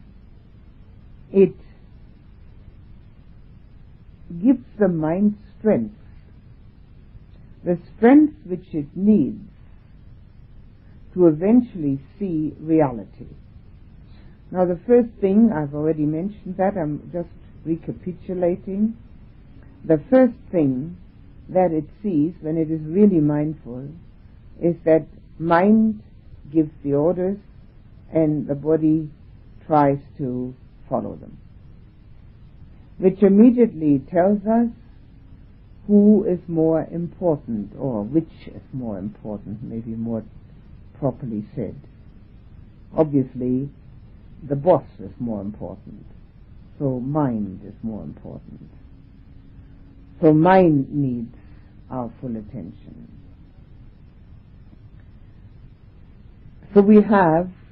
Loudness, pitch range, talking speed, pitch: -20 LUFS, 110-175 Hz, 90 wpm, 145 Hz